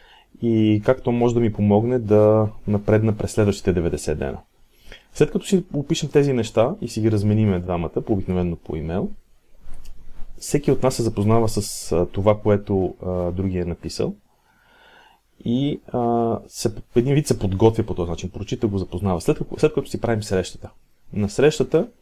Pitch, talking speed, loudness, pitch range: 110 Hz, 165 wpm, -21 LUFS, 100-130 Hz